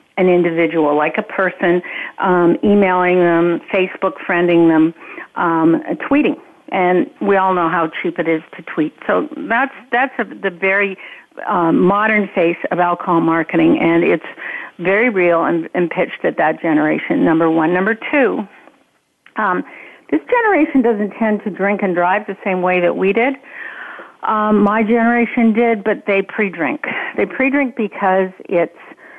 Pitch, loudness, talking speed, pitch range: 190 Hz, -16 LUFS, 155 wpm, 170-220 Hz